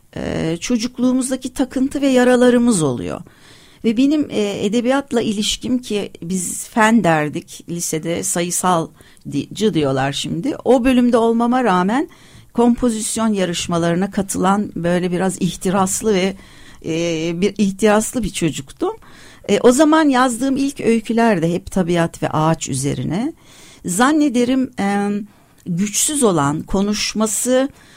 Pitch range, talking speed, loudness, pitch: 170-245 Hz, 115 wpm, -17 LUFS, 210 Hz